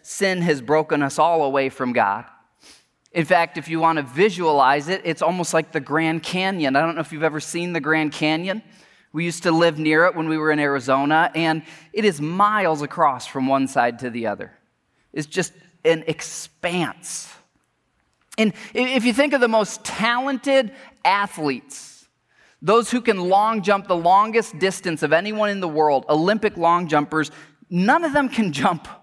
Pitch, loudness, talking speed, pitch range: 170 Hz, -20 LUFS, 180 wpm, 155-205 Hz